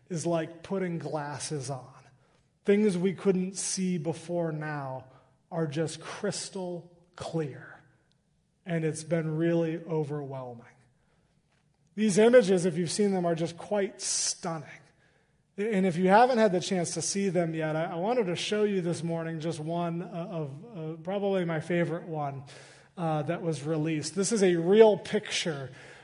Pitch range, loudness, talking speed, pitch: 155-185 Hz, -29 LUFS, 150 wpm, 165 Hz